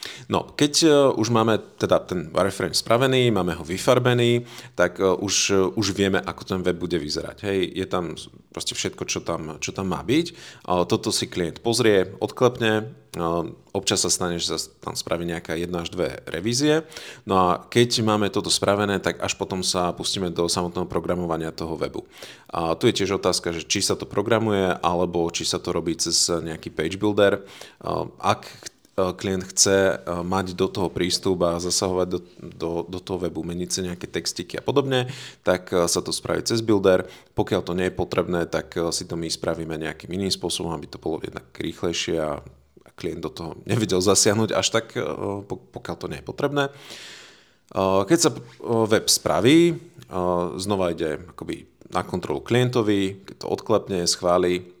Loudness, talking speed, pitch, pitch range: -23 LUFS, 170 wpm, 95 Hz, 85-110 Hz